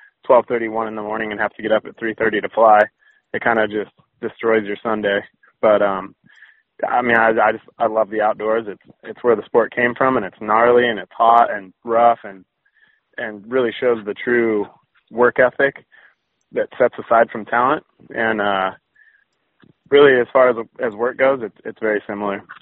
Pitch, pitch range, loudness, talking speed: 110 Hz, 105-120 Hz, -18 LUFS, 200 wpm